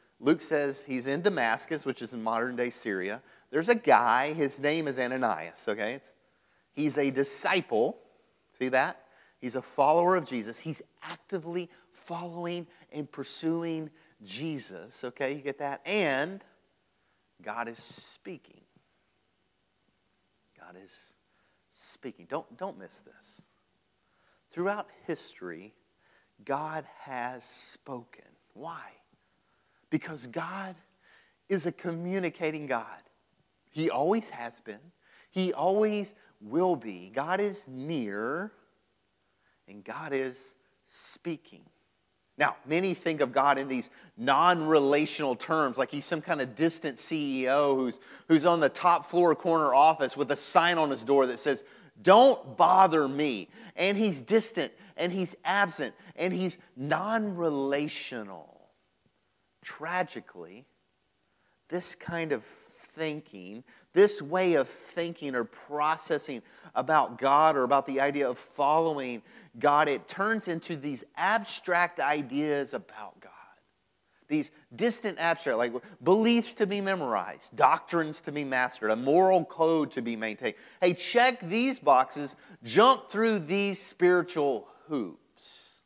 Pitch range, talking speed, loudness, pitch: 135-180 Hz, 125 wpm, -28 LUFS, 155 Hz